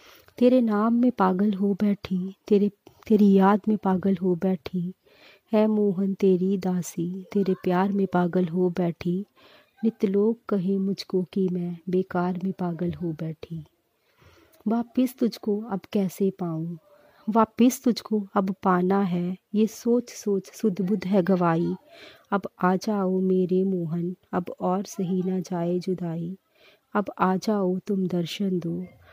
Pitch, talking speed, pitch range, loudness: 190 Hz, 140 wpm, 180-210 Hz, -25 LUFS